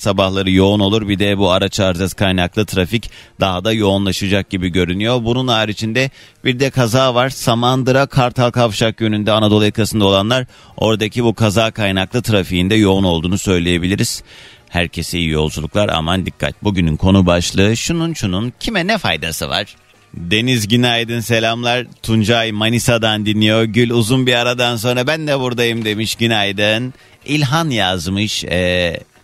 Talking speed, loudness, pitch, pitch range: 145 wpm, -15 LUFS, 110 Hz, 95-120 Hz